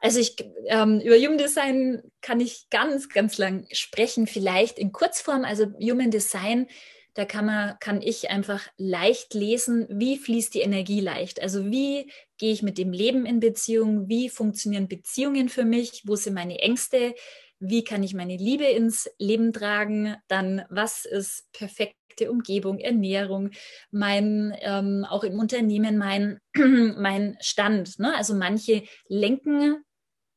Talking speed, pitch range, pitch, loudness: 150 wpm, 200-240 Hz, 215 Hz, -25 LUFS